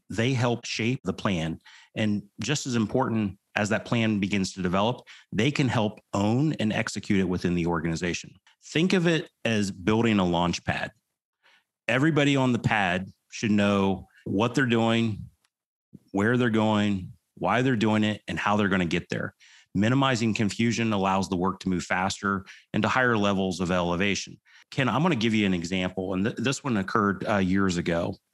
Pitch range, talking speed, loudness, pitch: 95-115 Hz, 180 wpm, -26 LUFS, 105 Hz